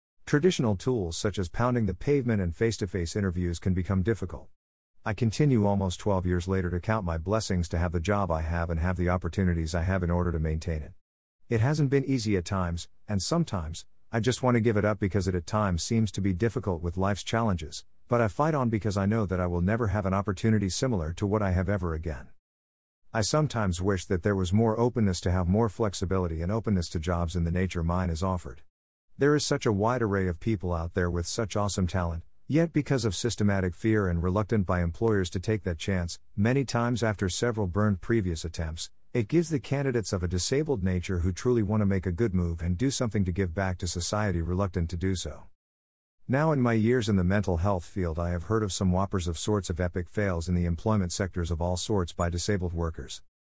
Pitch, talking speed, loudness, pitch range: 95 Hz, 230 wpm, -28 LUFS, 85-110 Hz